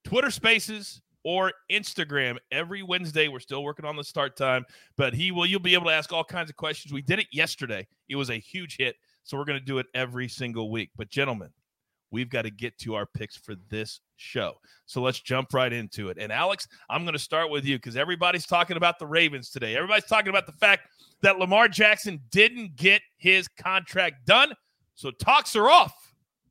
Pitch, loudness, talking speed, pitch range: 155 Hz, -24 LUFS, 210 wpm, 130-185 Hz